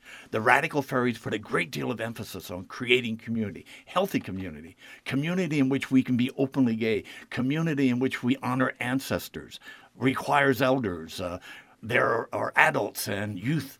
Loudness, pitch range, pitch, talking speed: -27 LUFS, 110-135 Hz, 125 Hz, 155 wpm